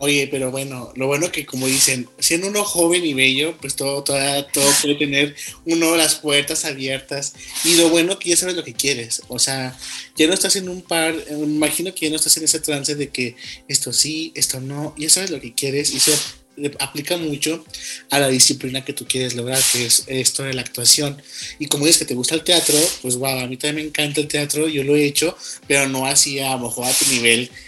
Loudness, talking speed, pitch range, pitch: -17 LUFS, 230 wpm, 130-155 Hz, 145 Hz